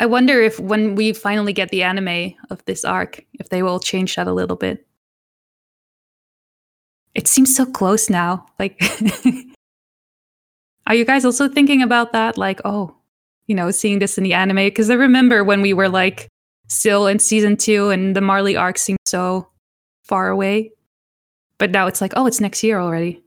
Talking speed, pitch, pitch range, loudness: 180 wpm, 200 Hz, 185-220 Hz, -16 LUFS